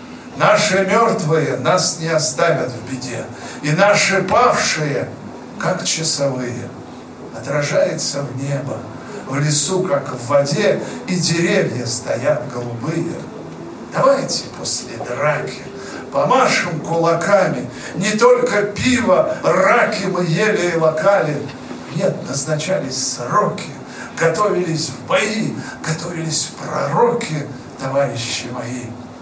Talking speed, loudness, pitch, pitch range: 100 wpm, -17 LUFS, 155 Hz, 135-195 Hz